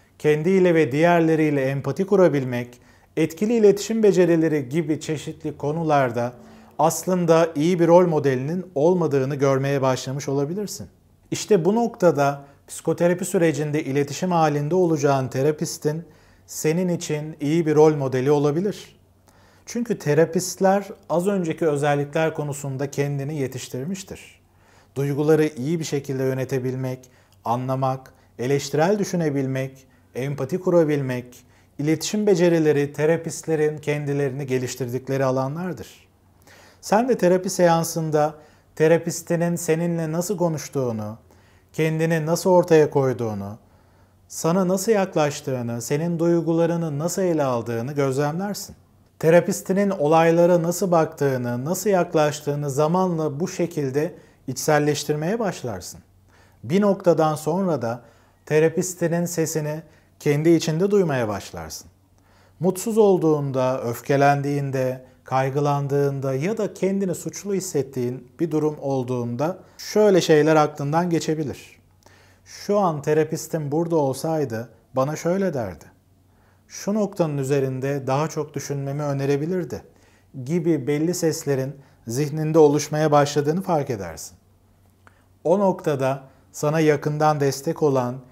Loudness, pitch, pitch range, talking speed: -22 LUFS, 150 Hz, 130-170 Hz, 100 wpm